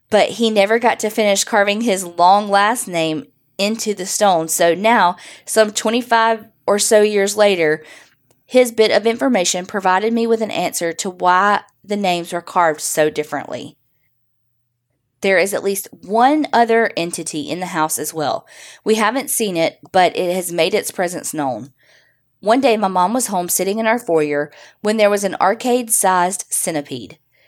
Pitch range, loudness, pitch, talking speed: 170-220 Hz, -16 LUFS, 195 Hz, 175 wpm